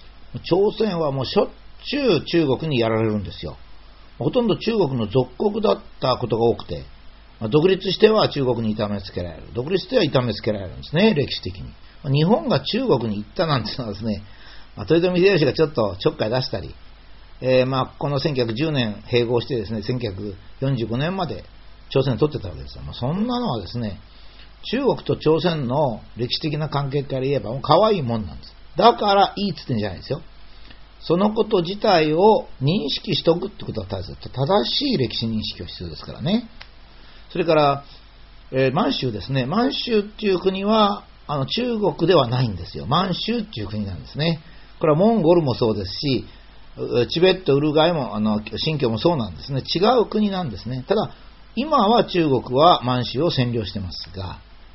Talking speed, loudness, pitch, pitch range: 365 characters per minute, -21 LUFS, 130 Hz, 110-175 Hz